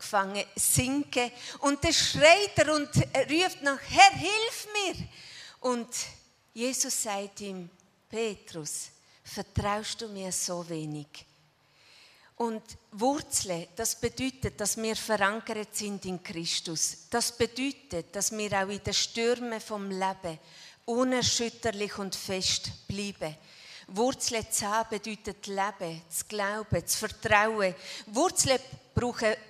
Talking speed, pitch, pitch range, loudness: 115 wpm, 215 Hz, 195-245 Hz, -28 LUFS